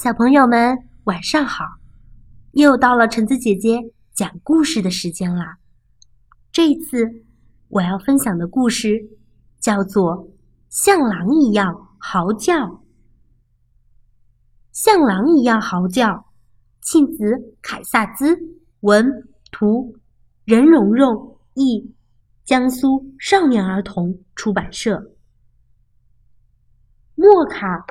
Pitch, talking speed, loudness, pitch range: 215 Hz, 150 characters per minute, -17 LUFS, 175-265 Hz